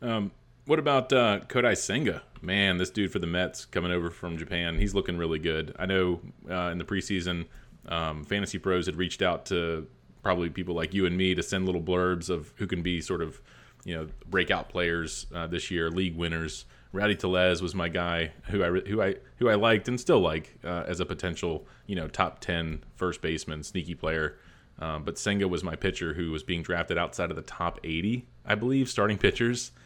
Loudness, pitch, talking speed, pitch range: -29 LUFS, 90 Hz, 210 wpm, 85-95 Hz